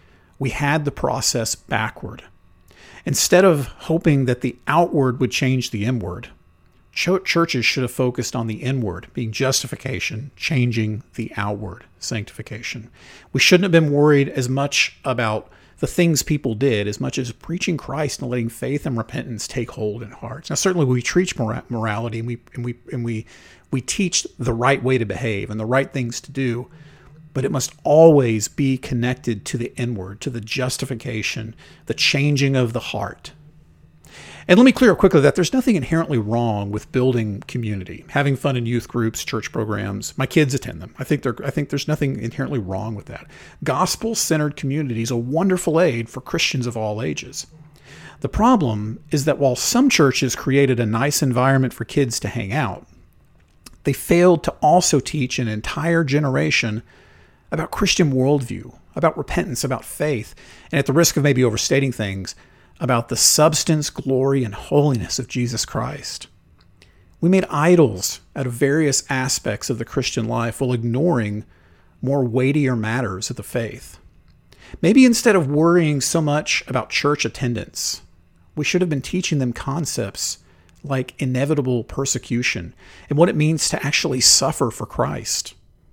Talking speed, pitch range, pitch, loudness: 165 wpm, 115-150 Hz, 130 Hz, -20 LUFS